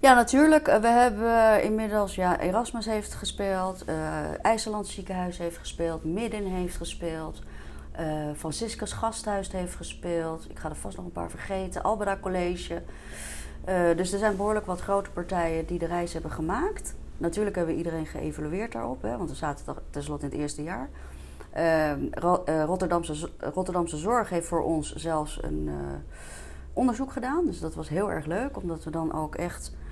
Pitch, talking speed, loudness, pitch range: 175 Hz, 165 wpm, -28 LUFS, 155-205 Hz